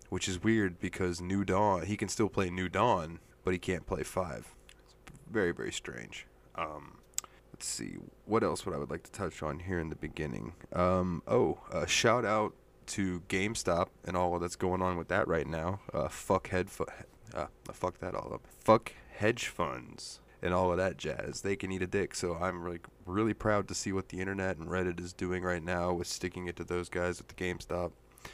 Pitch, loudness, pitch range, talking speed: 90 Hz, -34 LUFS, 85-95 Hz, 215 wpm